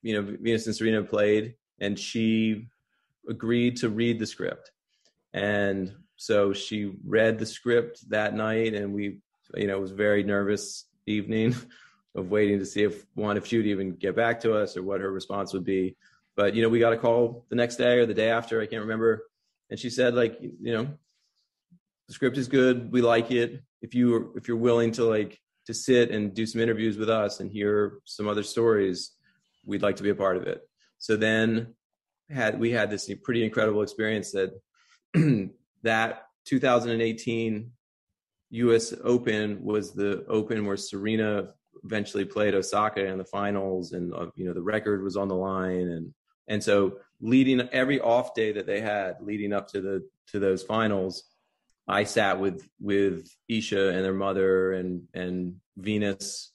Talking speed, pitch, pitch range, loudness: 185 wpm, 110 Hz, 100-115 Hz, -27 LUFS